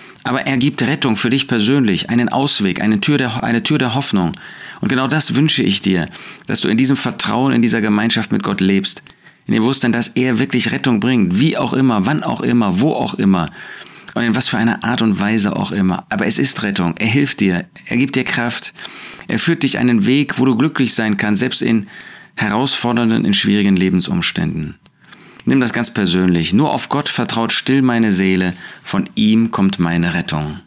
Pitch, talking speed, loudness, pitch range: 115 Hz, 200 wpm, -15 LUFS, 95-130 Hz